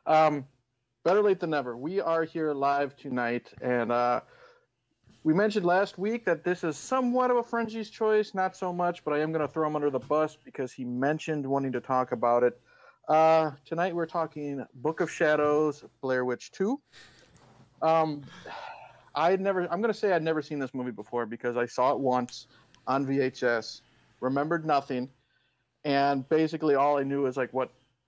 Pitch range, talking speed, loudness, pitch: 130-170 Hz, 180 wpm, -28 LUFS, 150 Hz